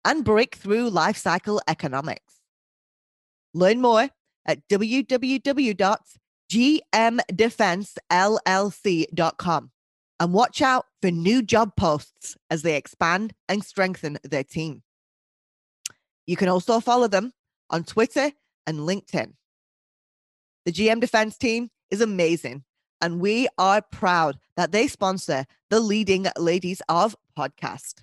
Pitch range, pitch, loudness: 170-225 Hz, 195 Hz, -23 LUFS